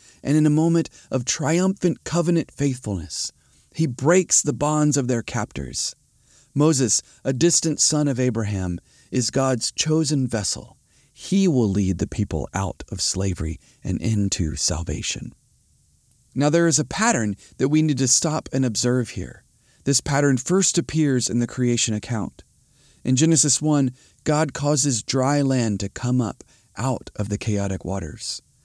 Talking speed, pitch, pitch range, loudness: 150 wpm, 130 Hz, 105-150 Hz, -22 LUFS